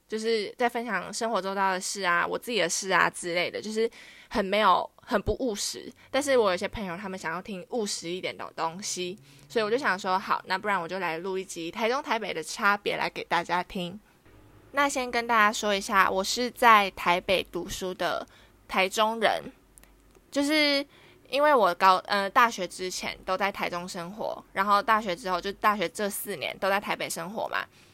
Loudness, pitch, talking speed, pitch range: -27 LUFS, 195 Hz, 285 characters per minute, 180-225 Hz